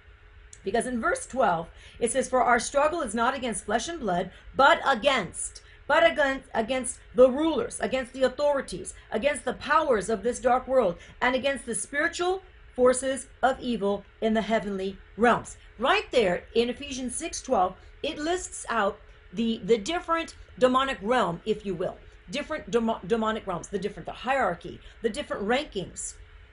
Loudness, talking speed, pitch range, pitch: -27 LUFS, 160 wpm, 205-275 Hz, 245 Hz